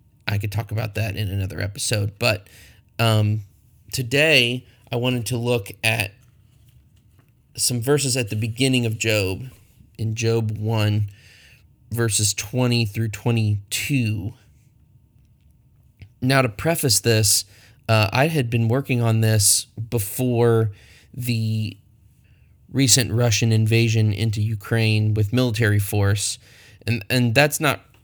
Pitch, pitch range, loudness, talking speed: 115 Hz, 105-120 Hz, -21 LUFS, 120 wpm